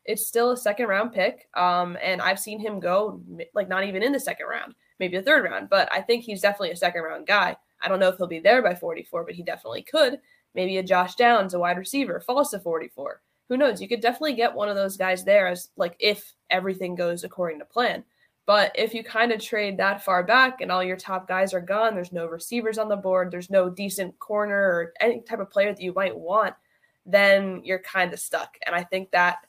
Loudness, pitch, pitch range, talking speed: -24 LUFS, 195 Hz, 185-230 Hz, 245 wpm